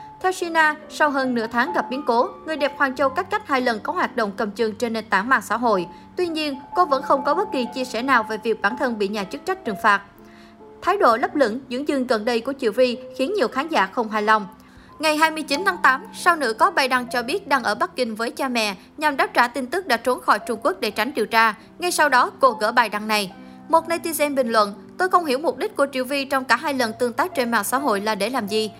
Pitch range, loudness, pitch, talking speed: 225-300 Hz, -21 LUFS, 255 Hz, 280 wpm